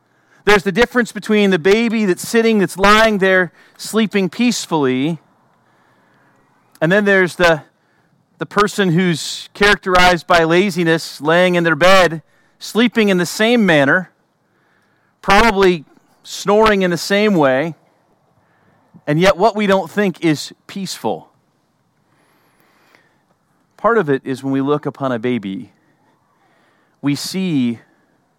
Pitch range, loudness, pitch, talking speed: 155-205 Hz, -15 LUFS, 180 Hz, 125 wpm